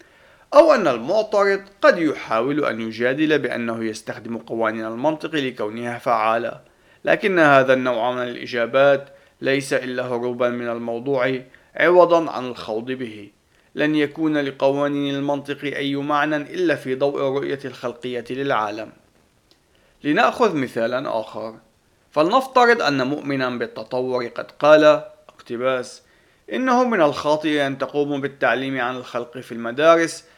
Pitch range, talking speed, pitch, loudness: 120-150 Hz, 115 wpm, 135 Hz, -20 LUFS